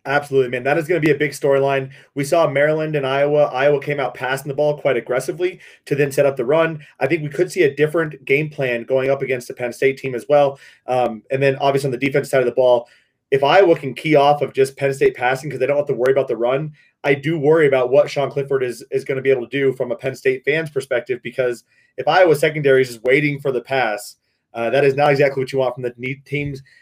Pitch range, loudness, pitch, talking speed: 130-150 Hz, -18 LUFS, 140 Hz, 265 wpm